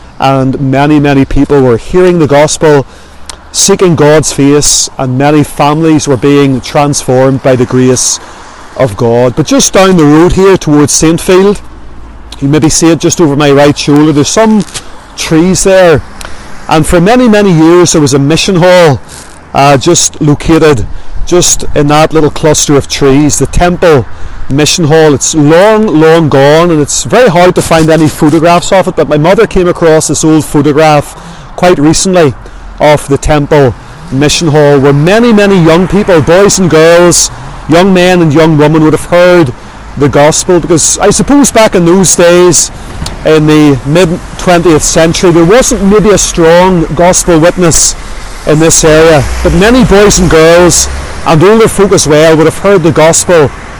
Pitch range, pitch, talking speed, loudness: 140-175 Hz, 155 Hz, 170 wpm, -5 LUFS